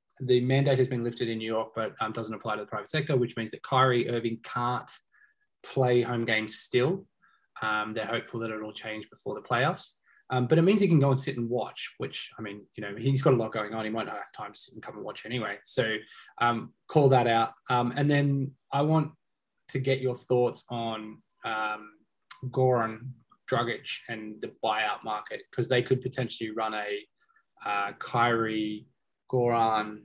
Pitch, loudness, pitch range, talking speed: 120 Hz, -29 LUFS, 110-130 Hz, 200 wpm